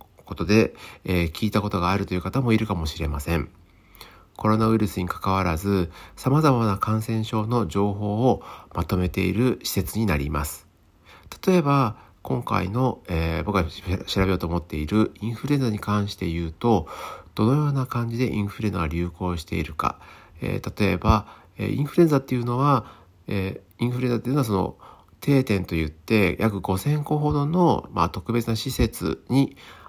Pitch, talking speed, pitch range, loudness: 105 Hz, 350 characters per minute, 90-120 Hz, -24 LUFS